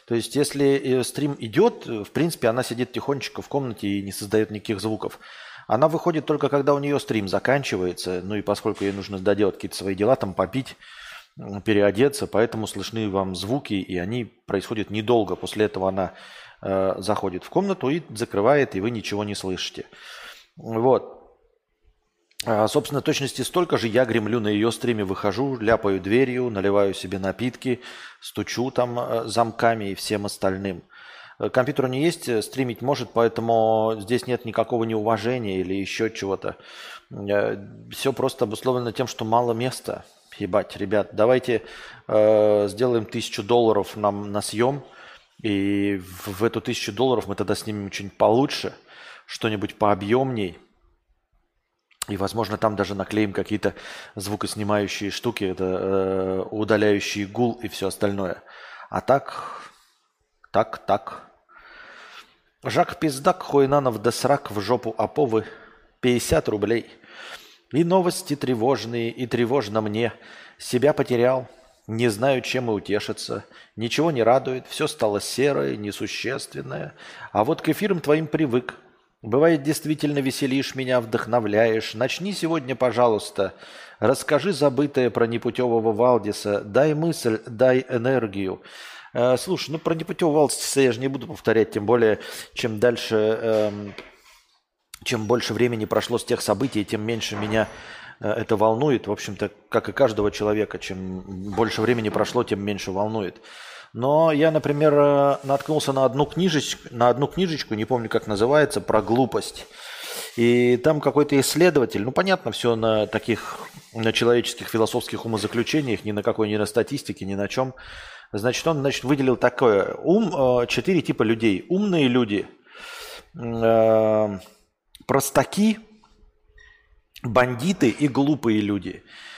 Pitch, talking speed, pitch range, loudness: 115 Hz, 135 wpm, 105-140 Hz, -23 LUFS